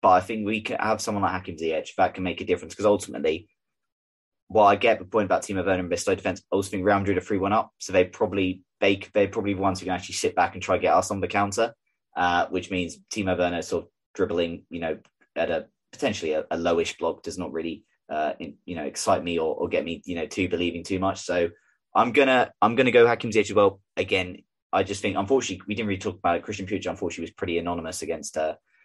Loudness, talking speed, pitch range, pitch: -25 LUFS, 260 wpm, 85-100 Hz, 95 Hz